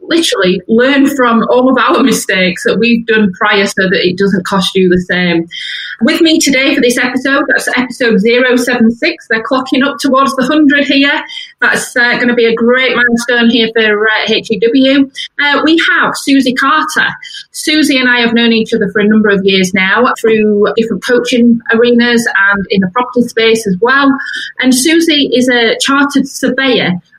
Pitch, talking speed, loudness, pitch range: 240 Hz, 180 wpm, -9 LUFS, 220-275 Hz